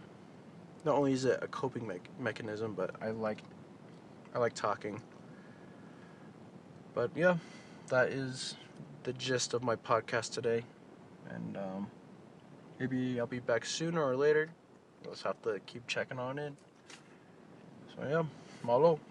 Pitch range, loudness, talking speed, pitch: 115-160 Hz, -35 LUFS, 140 wpm, 130 Hz